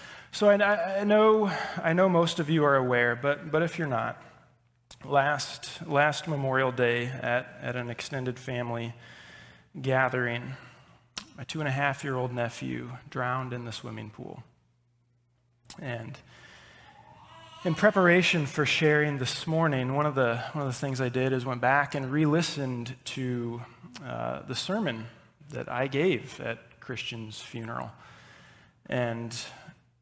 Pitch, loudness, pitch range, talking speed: 130 Hz, -28 LUFS, 120-150 Hz, 145 wpm